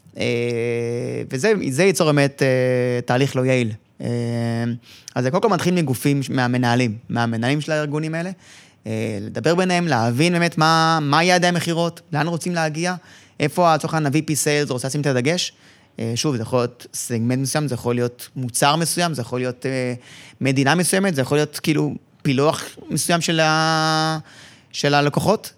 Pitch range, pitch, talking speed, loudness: 125-160 Hz, 145 Hz, 155 wpm, -20 LUFS